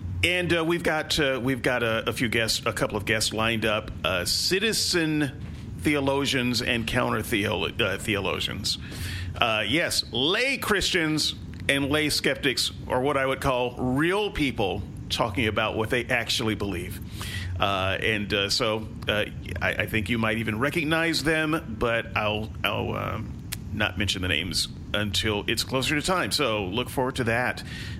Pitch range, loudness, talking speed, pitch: 105-135 Hz, -25 LUFS, 165 wpm, 115 Hz